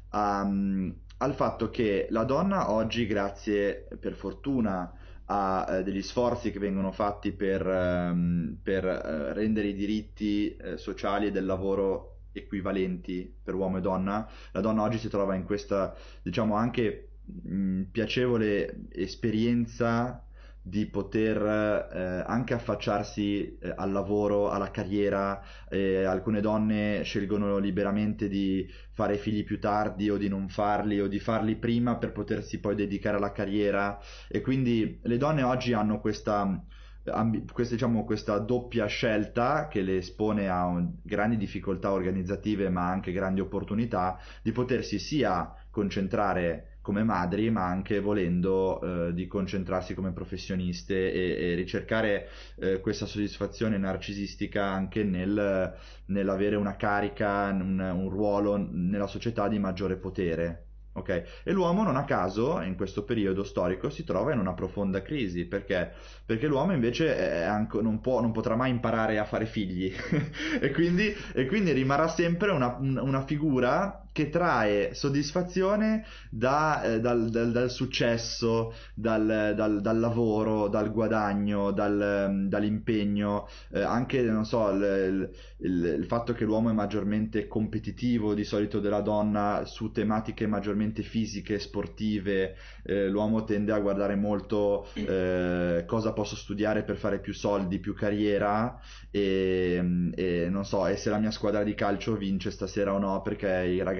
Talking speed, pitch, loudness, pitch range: 145 wpm, 105 Hz, -29 LUFS, 95-110 Hz